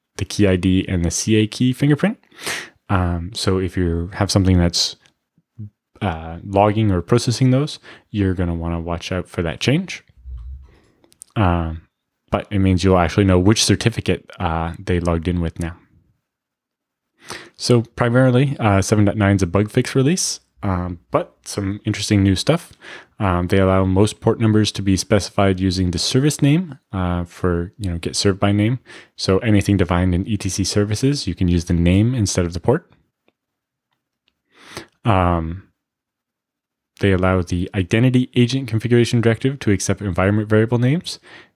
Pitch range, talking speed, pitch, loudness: 90-115 Hz, 155 wpm, 100 Hz, -19 LUFS